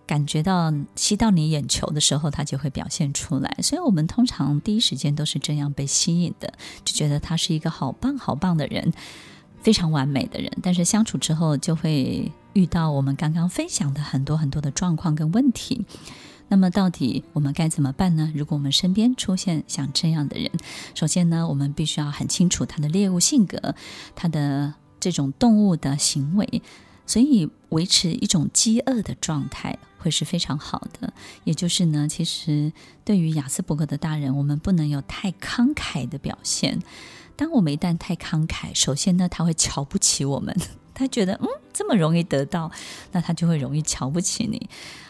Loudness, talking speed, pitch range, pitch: -22 LUFS, 285 characters per minute, 145-190 Hz, 165 Hz